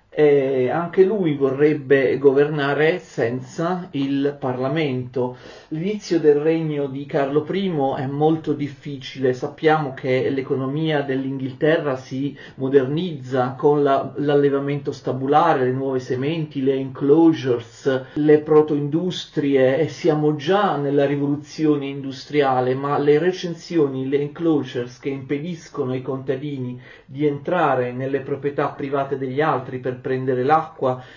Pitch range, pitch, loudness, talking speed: 135-155 Hz, 145 Hz, -21 LUFS, 115 wpm